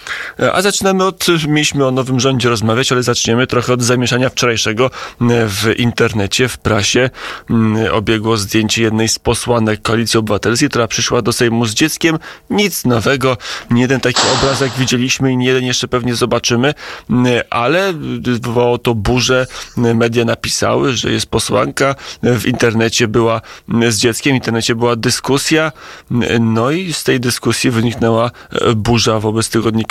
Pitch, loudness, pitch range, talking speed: 120 Hz, -14 LUFS, 115-130 Hz, 145 wpm